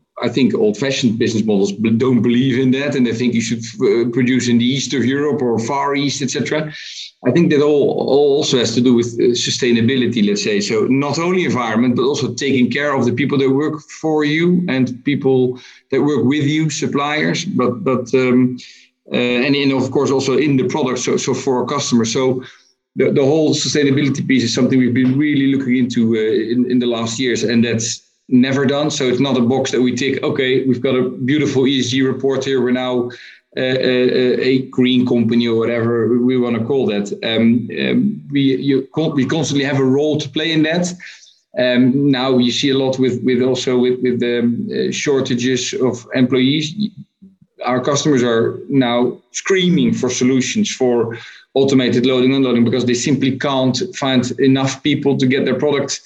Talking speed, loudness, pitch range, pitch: 195 wpm, -16 LUFS, 125-140 Hz, 130 Hz